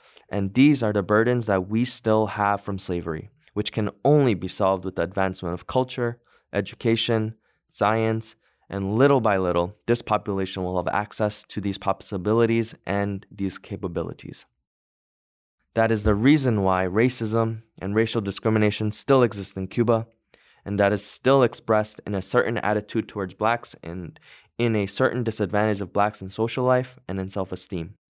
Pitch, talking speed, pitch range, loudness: 105 Hz, 160 wpm, 95-115 Hz, -24 LUFS